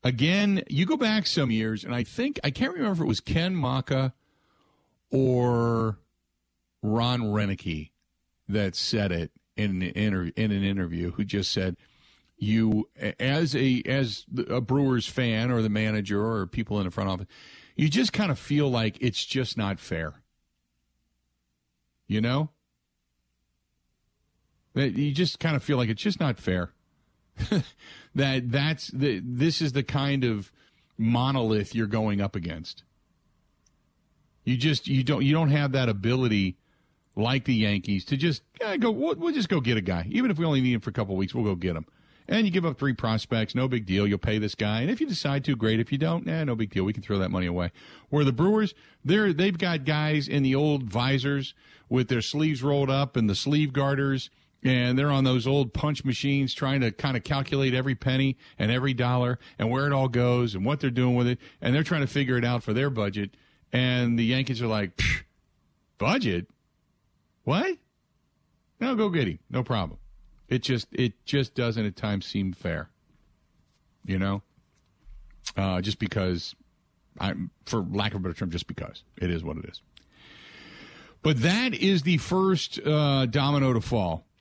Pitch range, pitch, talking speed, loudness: 100-140 Hz, 125 Hz, 185 wpm, -27 LUFS